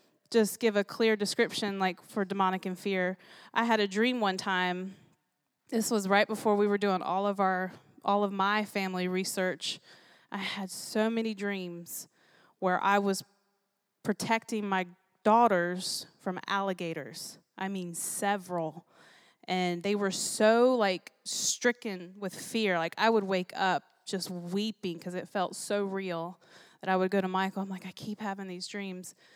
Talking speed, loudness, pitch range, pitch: 165 wpm, -30 LUFS, 185-210 Hz, 195 Hz